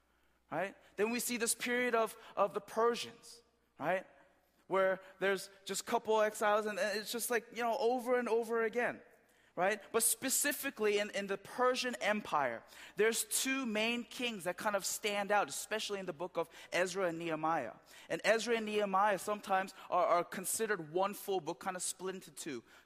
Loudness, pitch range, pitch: -35 LUFS, 190-235 Hz, 210 Hz